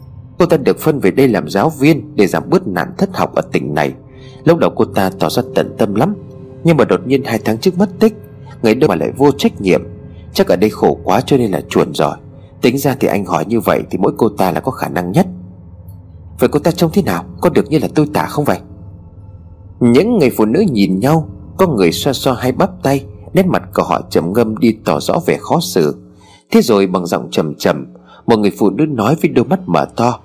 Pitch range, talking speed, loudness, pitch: 95-155 Hz, 245 wpm, -14 LUFS, 125 Hz